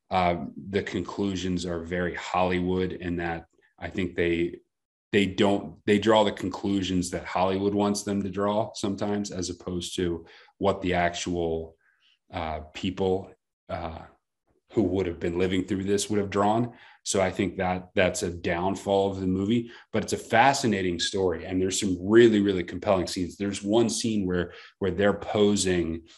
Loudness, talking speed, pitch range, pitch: -26 LUFS, 165 wpm, 90-100 Hz, 95 Hz